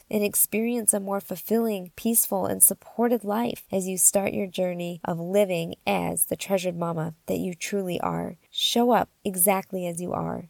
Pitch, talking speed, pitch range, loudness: 195 Hz, 170 wpm, 175-210 Hz, -24 LUFS